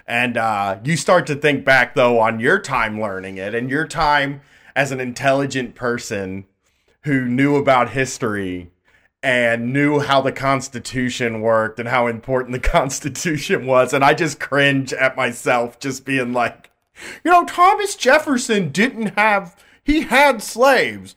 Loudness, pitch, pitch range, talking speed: -18 LUFS, 130 Hz, 120-150 Hz, 155 wpm